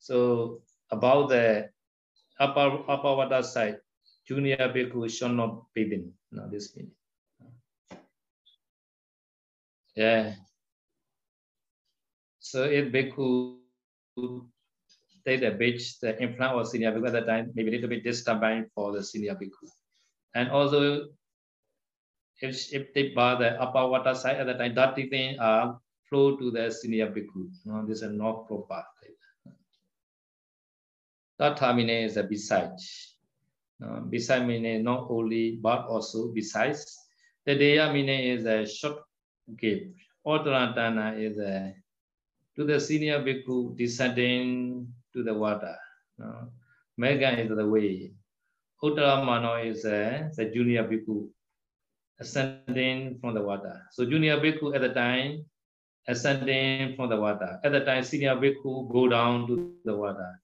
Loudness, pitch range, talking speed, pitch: -28 LUFS, 110-135 Hz, 130 wpm, 125 Hz